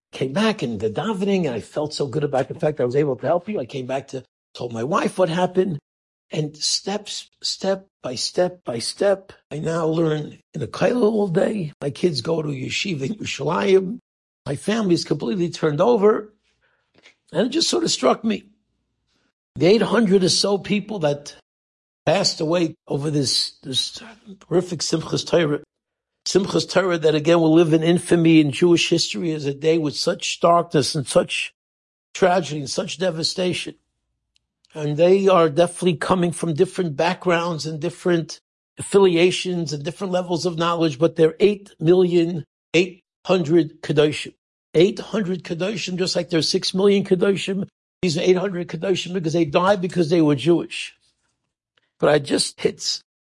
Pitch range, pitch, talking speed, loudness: 155-190 Hz, 175 Hz, 165 wpm, -20 LUFS